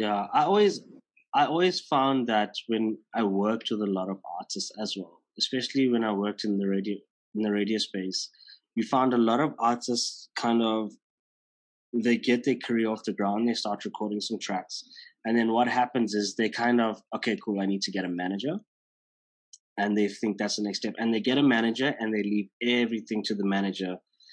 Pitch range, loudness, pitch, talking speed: 105-120 Hz, -27 LUFS, 110 Hz, 205 wpm